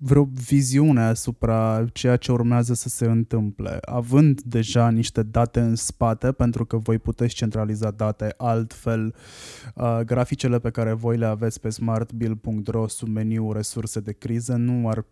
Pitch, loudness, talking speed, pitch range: 115 Hz, -23 LUFS, 150 wpm, 110-120 Hz